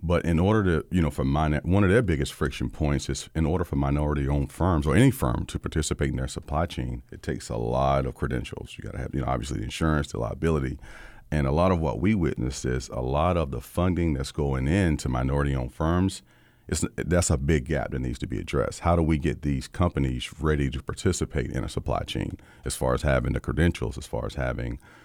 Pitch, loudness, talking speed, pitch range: 75 Hz, -26 LUFS, 235 wpm, 65-85 Hz